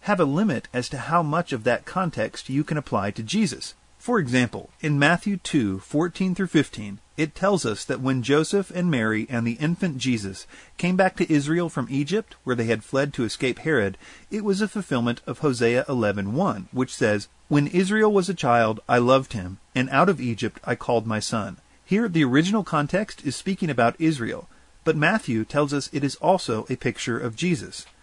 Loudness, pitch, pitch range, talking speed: -24 LUFS, 140 Hz, 120-175 Hz, 200 wpm